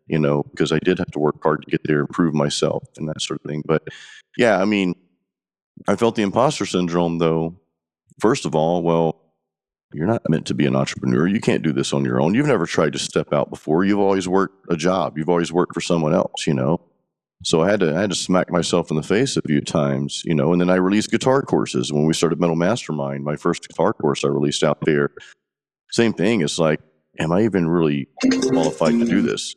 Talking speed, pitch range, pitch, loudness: 235 wpm, 75-90 Hz, 85 Hz, -20 LUFS